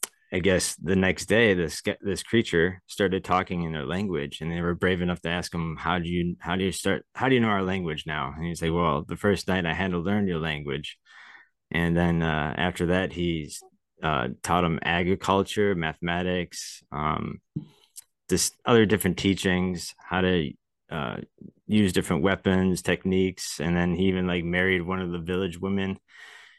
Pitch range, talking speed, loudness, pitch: 85-95 Hz, 185 wpm, -26 LUFS, 90 Hz